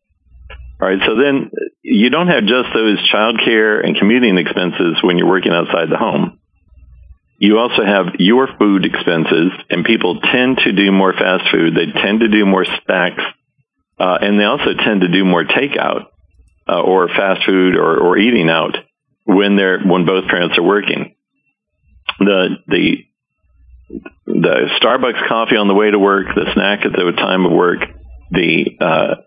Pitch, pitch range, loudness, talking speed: 95 Hz, 80-105 Hz, -13 LUFS, 170 wpm